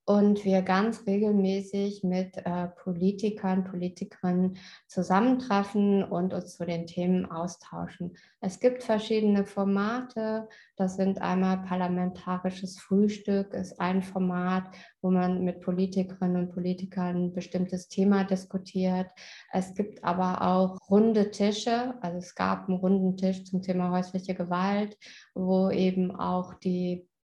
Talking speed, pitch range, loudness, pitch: 125 wpm, 180-200 Hz, -28 LUFS, 185 Hz